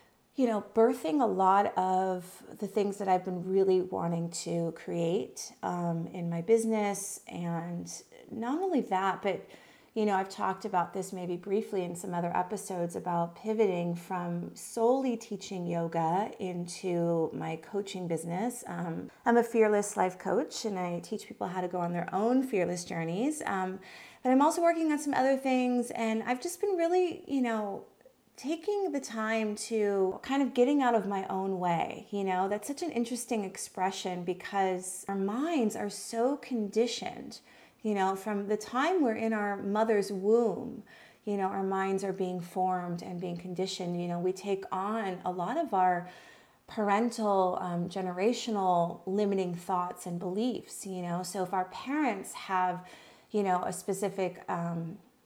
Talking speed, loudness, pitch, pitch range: 165 wpm, -31 LUFS, 195 Hz, 180-225 Hz